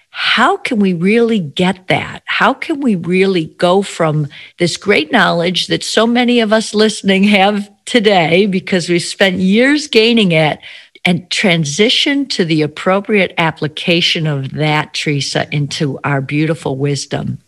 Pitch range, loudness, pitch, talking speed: 155-215 Hz, -13 LUFS, 185 Hz, 145 wpm